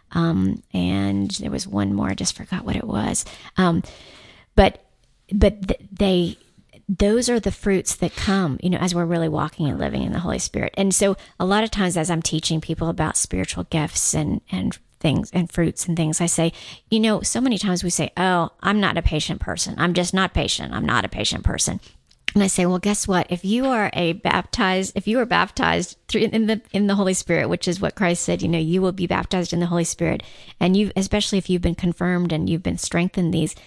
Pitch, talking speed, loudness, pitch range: 180 Hz, 230 wpm, -21 LUFS, 165-195 Hz